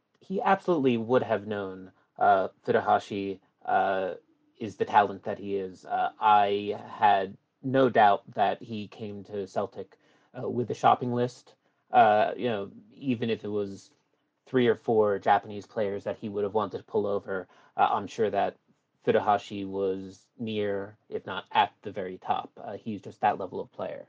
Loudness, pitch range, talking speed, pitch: -28 LUFS, 100-130 Hz, 170 wpm, 105 Hz